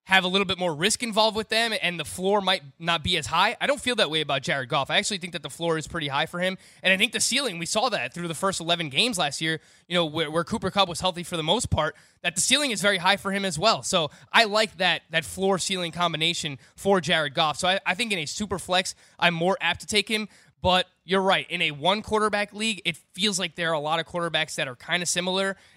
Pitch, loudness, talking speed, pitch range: 185 Hz, -24 LUFS, 280 wpm, 170-200 Hz